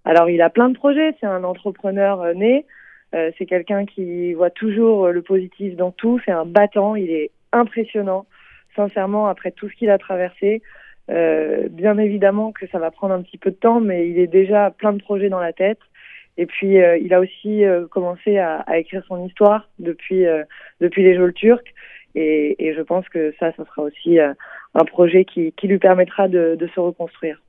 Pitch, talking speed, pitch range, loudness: 185 Hz, 210 wpm, 175-205 Hz, -18 LUFS